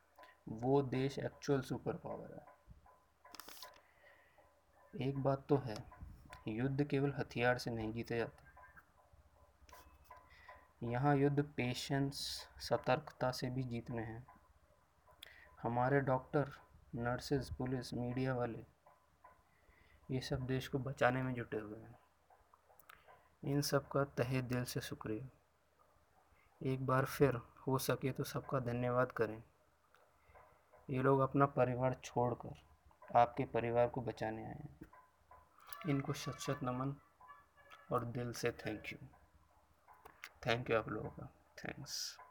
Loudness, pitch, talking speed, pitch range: -39 LUFS, 130 Hz, 115 wpm, 120-140 Hz